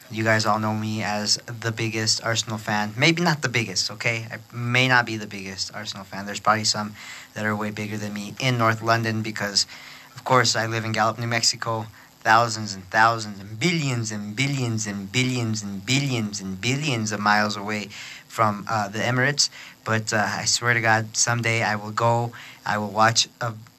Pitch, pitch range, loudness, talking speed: 110 Hz, 105-120 Hz, -23 LUFS, 195 wpm